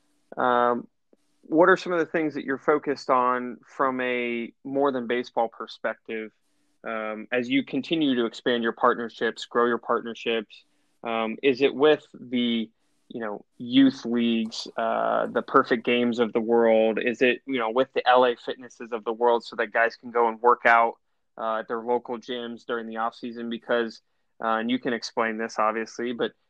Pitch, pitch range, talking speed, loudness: 120 Hz, 115-130 Hz, 185 wpm, -25 LUFS